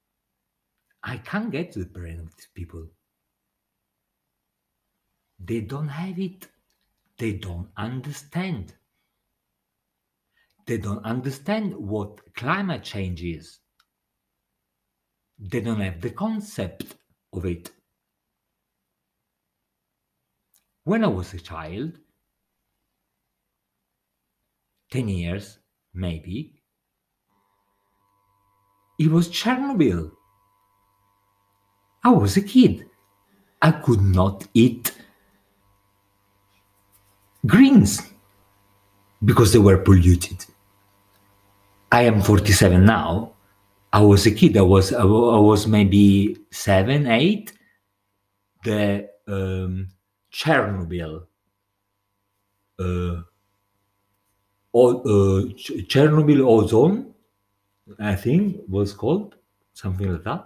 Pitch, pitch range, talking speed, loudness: 100 Hz, 100-115 Hz, 85 wpm, -20 LUFS